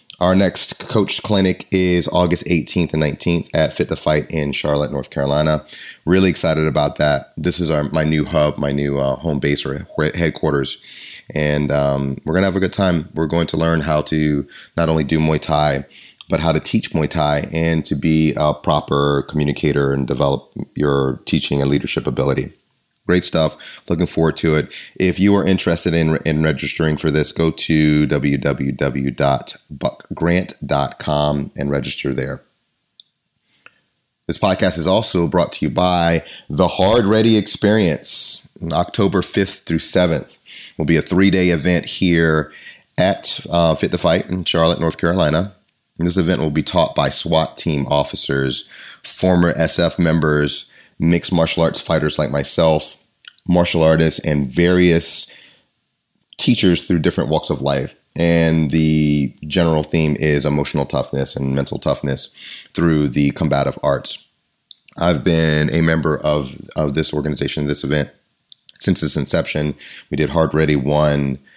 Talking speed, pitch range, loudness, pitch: 160 wpm, 70-85 Hz, -17 LUFS, 75 Hz